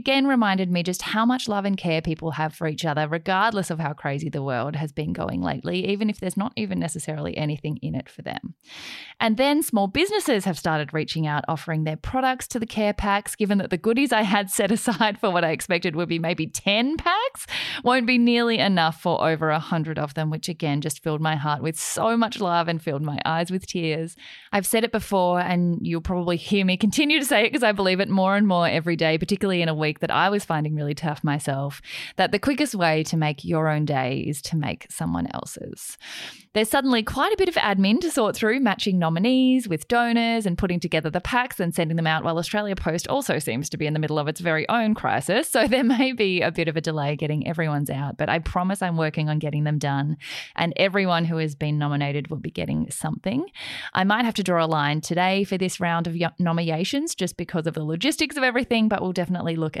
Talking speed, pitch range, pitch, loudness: 235 wpm, 155-215 Hz, 175 Hz, -23 LUFS